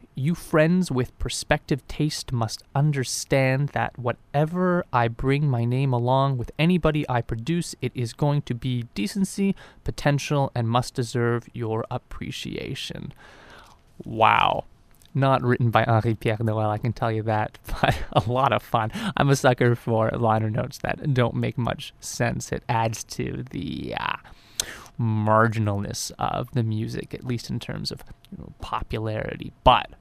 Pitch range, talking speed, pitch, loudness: 115-140 Hz, 150 wpm, 125 Hz, -24 LUFS